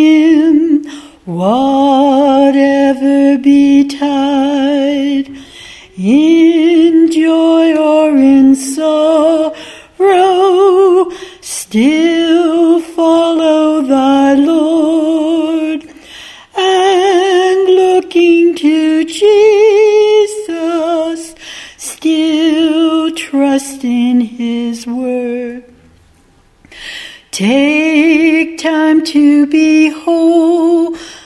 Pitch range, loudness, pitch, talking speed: 275-330 Hz, -10 LUFS, 315 Hz, 50 wpm